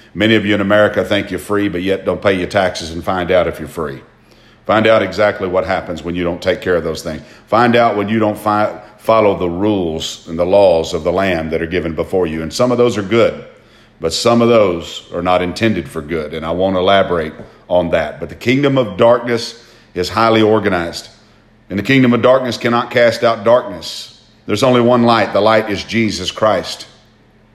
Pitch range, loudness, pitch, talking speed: 90-115 Hz, -14 LUFS, 105 Hz, 220 wpm